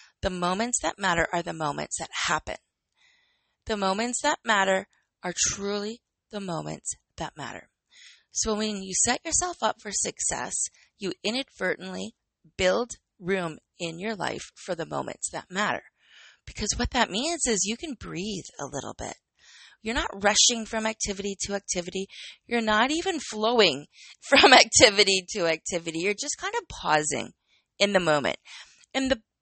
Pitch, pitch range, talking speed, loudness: 210 Hz, 190-240 Hz, 155 wpm, -25 LUFS